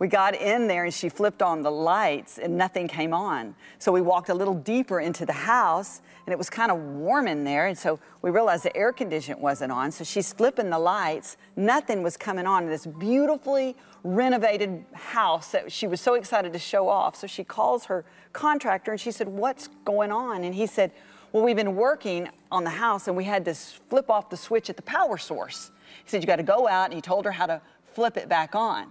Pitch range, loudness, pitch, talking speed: 175-225 Hz, -25 LUFS, 190 Hz, 230 wpm